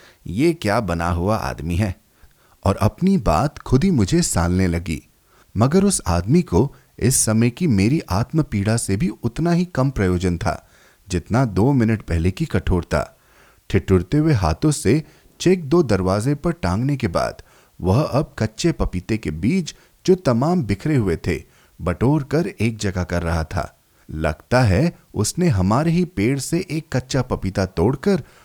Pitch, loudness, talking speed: 110 Hz, -20 LUFS, 160 wpm